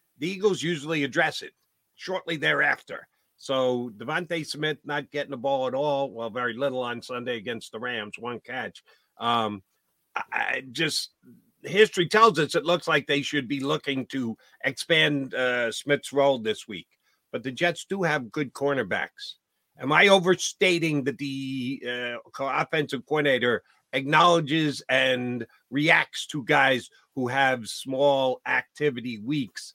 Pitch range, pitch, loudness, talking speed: 130-165 Hz, 140 Hz, -25 LUFS, 145 wpm